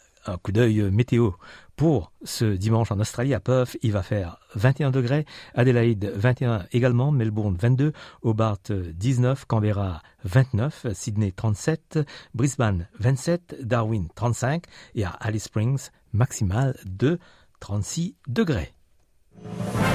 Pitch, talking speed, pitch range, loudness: 120 Hz, 115 wpm, 105-130 Hz, -24 LUFS